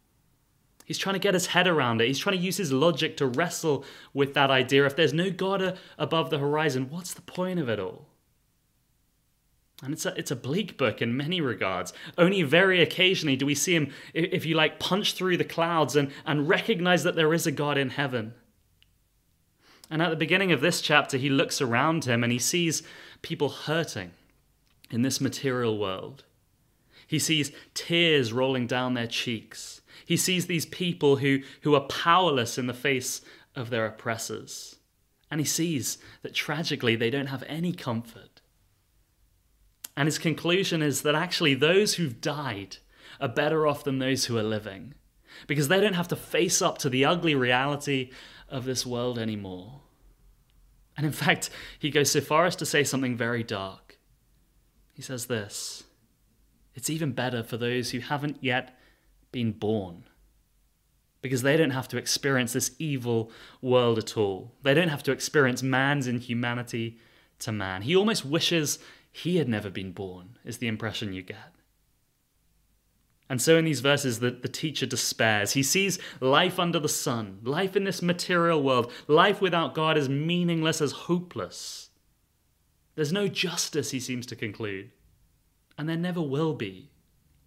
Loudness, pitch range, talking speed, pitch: -26 LUFS, 120-160 Hz, 170 wpm, 140 Hz